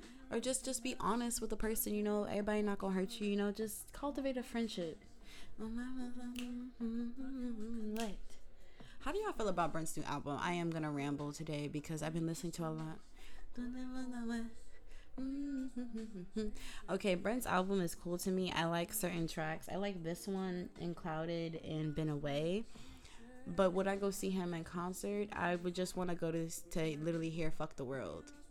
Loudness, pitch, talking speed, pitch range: -40 LUFS, 190 Hz, 170 wpm, 165-230 Hz